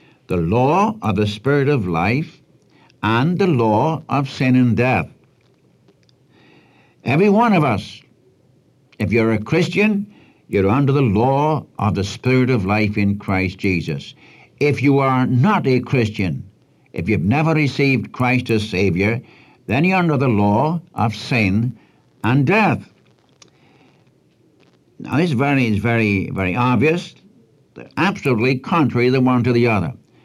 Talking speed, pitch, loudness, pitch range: 145 wpm, 125 Hz, -18 LUFS, 105-145 Hz